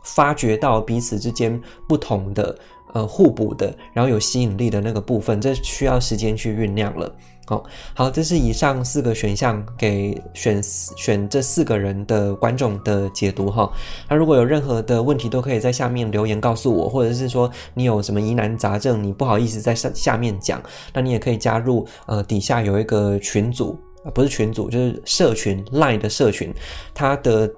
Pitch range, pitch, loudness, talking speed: 105-125 Hz, 115 Hz, -20 LUFS, 290 characters per minute